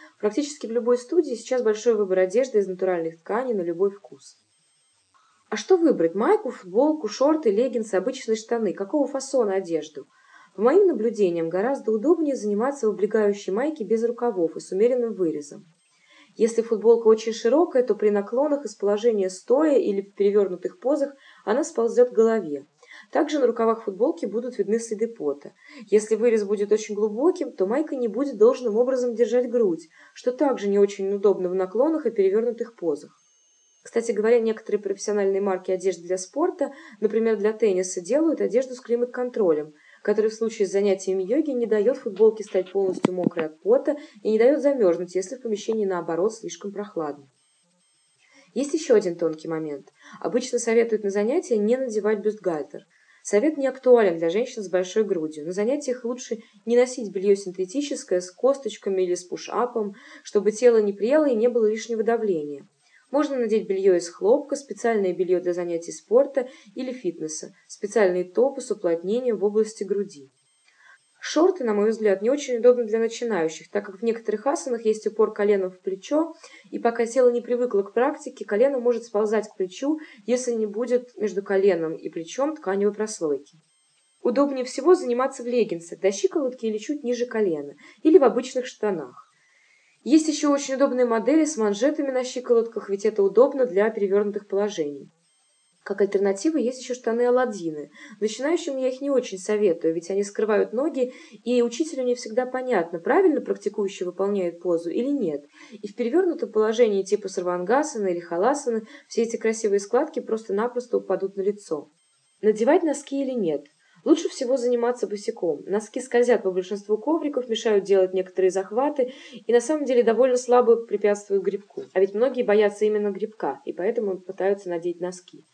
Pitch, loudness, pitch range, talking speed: 225 Hz, -24 LUFS, 195-255 Hz, 160 wpm